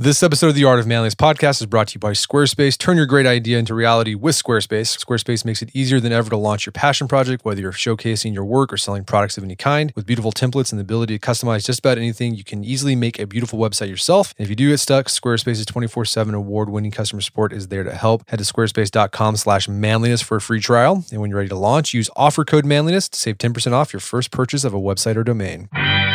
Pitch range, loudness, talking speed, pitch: 105-130 Hz, -18 LUFS, 245 wpm, 115 Hz